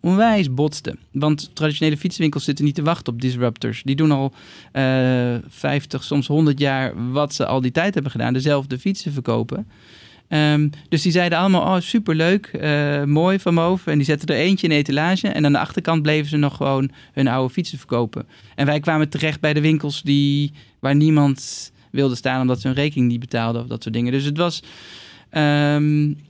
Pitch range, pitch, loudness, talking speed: 130-155 Hz, 145 Hz, -20 LUFS, 195 wpm